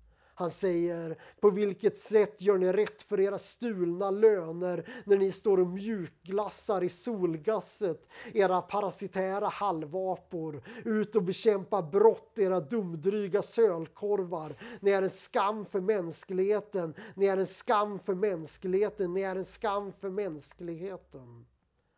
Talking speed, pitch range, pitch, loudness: 130 wpm, 180-205 Hz, 195 Hz, -30 LUFS